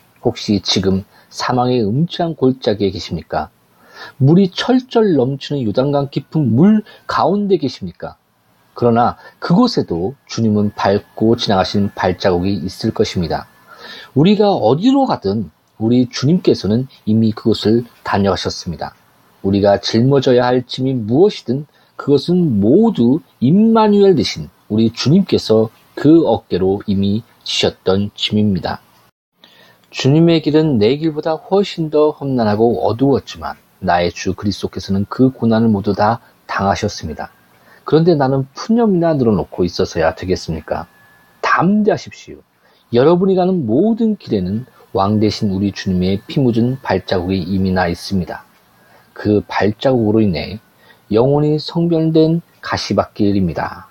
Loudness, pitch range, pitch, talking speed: -15 LUFS, 100-160 Hz, 120 Hz, 290 characters per minute